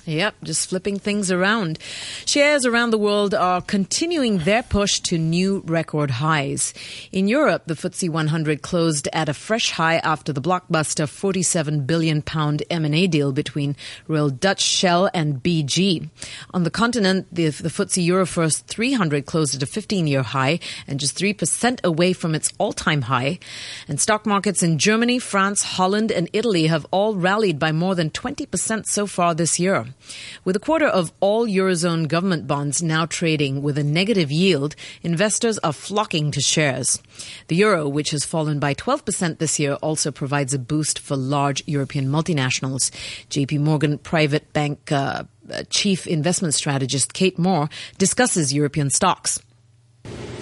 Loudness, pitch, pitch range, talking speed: -20 LUFS, 165 Hz, 145-190 Hz, 155 wpm